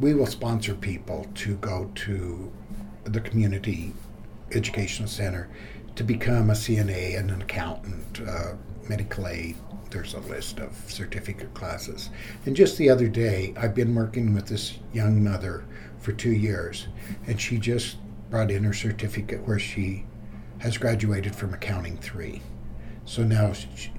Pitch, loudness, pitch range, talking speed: 105 Hz, -27 LUFS, 100-110 Hz, 150 wpm